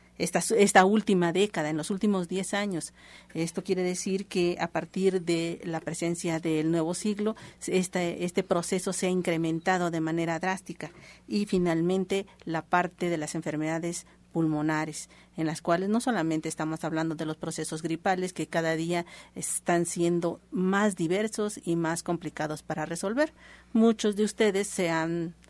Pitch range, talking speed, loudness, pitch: 160-190 Hz, 155 wpm, -28 LUFS, 175 Hz